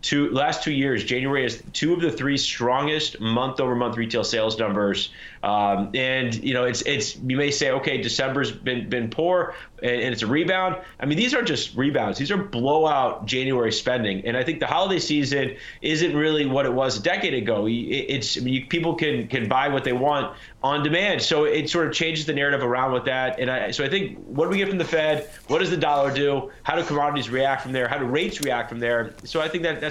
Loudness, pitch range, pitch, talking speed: -23 LUFS, 125-155 Hz, 135 Hz, 235 wpm